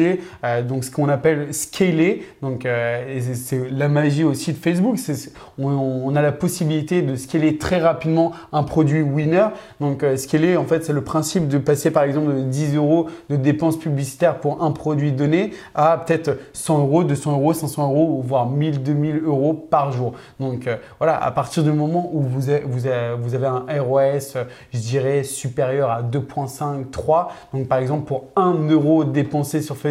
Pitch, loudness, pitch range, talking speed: 145 Hz, -20 LUFS, 135-155 Hz, 175 wpm